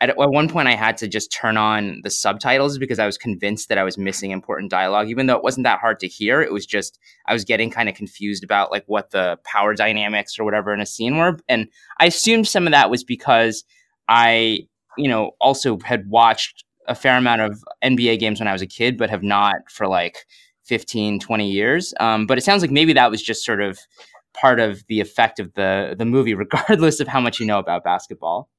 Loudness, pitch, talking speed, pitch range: -18 LUFS, 110 Hz, 230 wpm, 105-125 Hz